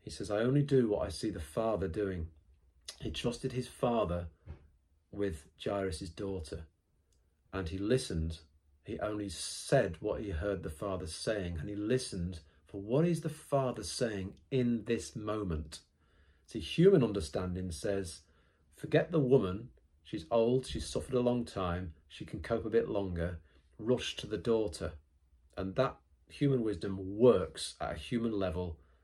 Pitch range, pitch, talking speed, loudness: 80-110 Hz, 95 Hz, 155 wpm, -34 LUFS